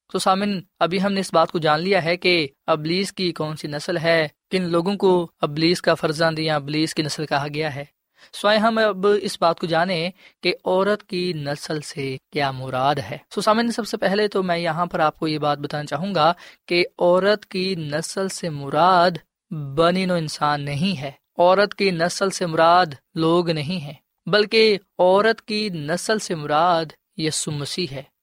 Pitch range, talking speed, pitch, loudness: 155-190 Hz, 190 wpm, 170 Hz, -21 LUFS